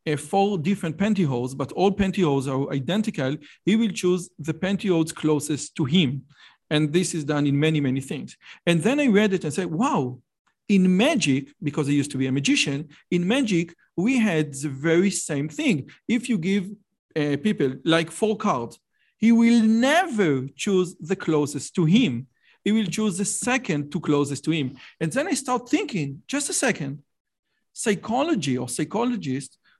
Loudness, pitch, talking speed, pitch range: -23 LUFS, 175 Hz, 175 wpm, 145-210 Hz